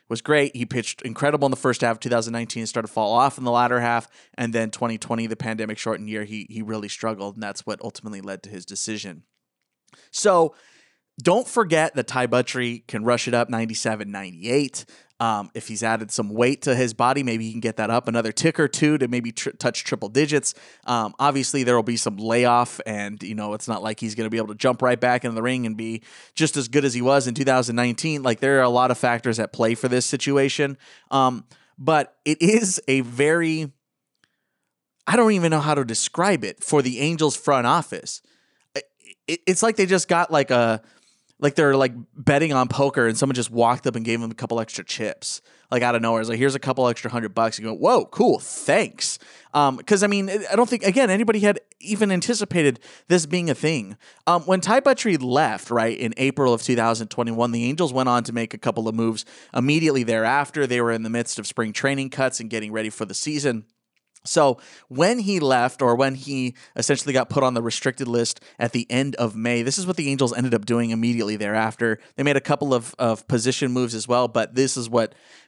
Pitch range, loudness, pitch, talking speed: 115-140 Hz, -22 LUFS, 125 Hz, 220 wpm